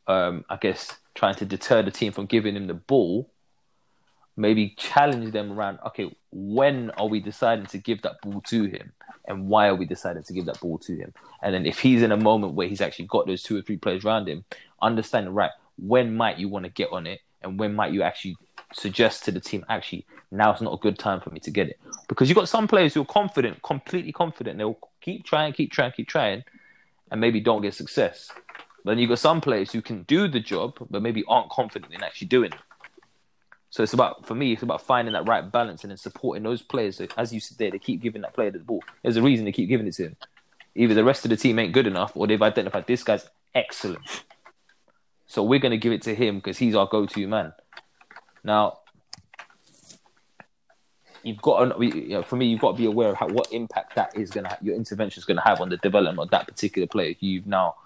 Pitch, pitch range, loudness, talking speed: 110 Hz, 100-120 Hz, -24 LUFS, 240 wpm